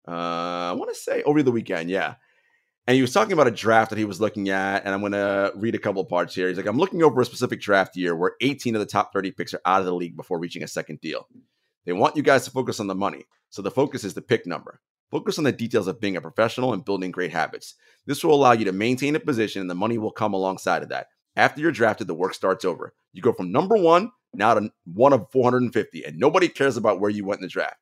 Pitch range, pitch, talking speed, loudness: 95-125 Hz, 105 Hz, 270 wpm, -23 LUFS